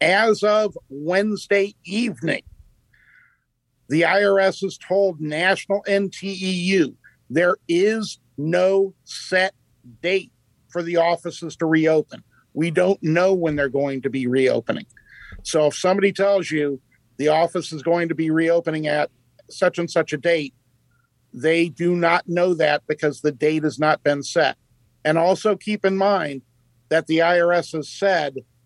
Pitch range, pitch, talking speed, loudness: 145-190 Hz, 165 Hz, 145 wpm, -21 LUFS